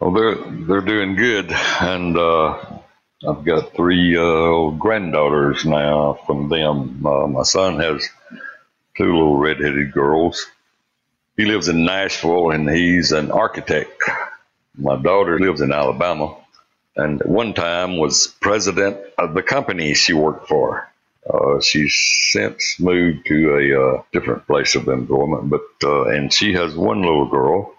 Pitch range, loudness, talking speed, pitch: 75-90 Hz, -17 LUFS, 145 wpm, 80 Hz